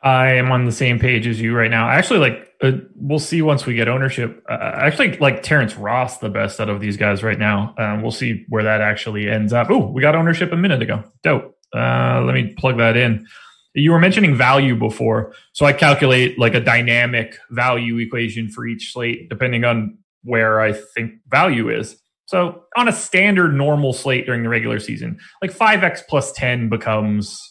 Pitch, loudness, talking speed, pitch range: 120 Hz, -17 LUFS, 200 wpm, 110-140 Hz